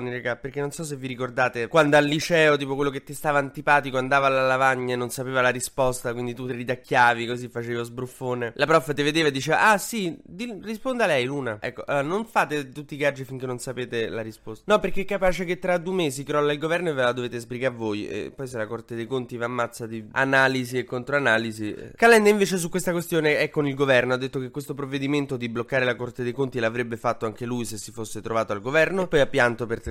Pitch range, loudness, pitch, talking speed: 120-150 Hz, -24 LUFS, 130 Hz, 245 wpm